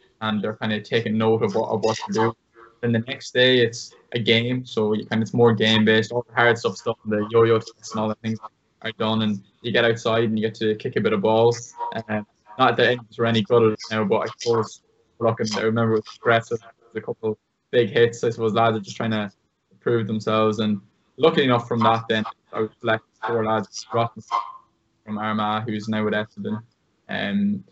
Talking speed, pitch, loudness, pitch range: 215 wpm, 110 Hz, -22 LUFS, 110-115 Hz